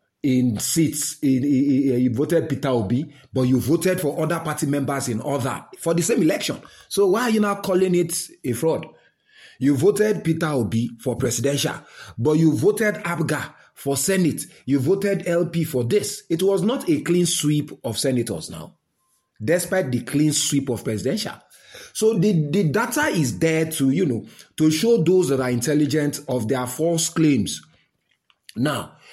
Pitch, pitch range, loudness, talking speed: 150 Hz, 135-175 Hz, -21 LUFS, 165 wpm